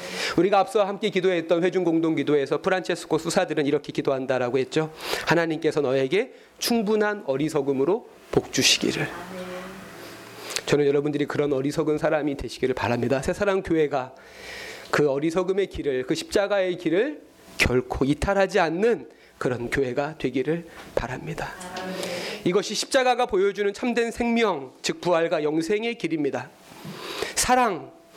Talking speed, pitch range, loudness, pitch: 330 characters per minute, 145-200 Hz, -24 LUFS, 170 Hz